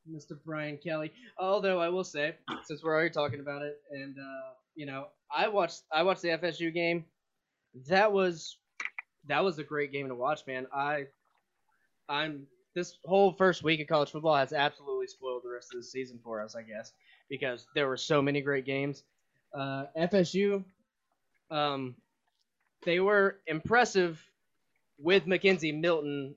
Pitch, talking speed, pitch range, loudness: 155 Hz, 160 wpm, 140-185 Hz, -31 LUFS